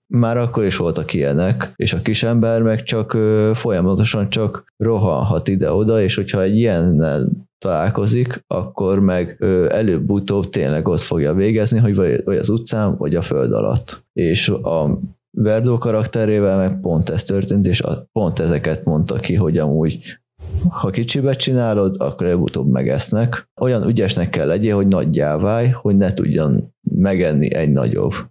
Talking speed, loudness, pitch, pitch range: 150 wpm, -17 LUFS, 105 Hz, 95-115 Hz